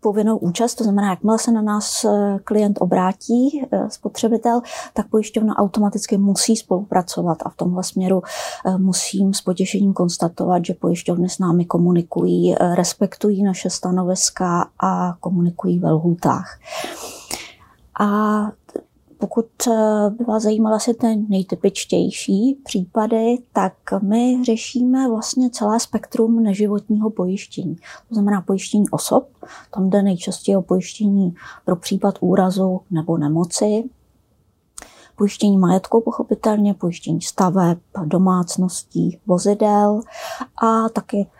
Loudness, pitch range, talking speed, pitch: -19 LUFS, 185-220 Hz, 110 wpm, 205 Hz